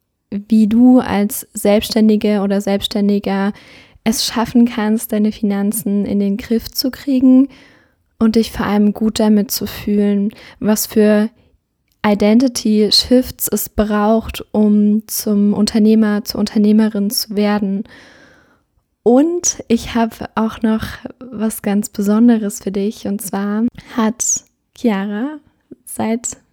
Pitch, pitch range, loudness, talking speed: 215 Hz, 205-230 Hz, -15 LUFS, 120 wpm